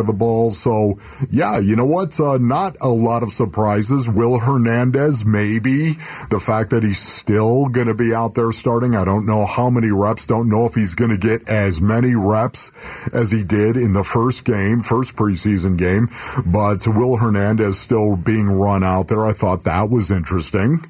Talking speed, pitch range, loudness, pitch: 195 wpm, 105-120 Hz, -17 LUFS, 110 Hz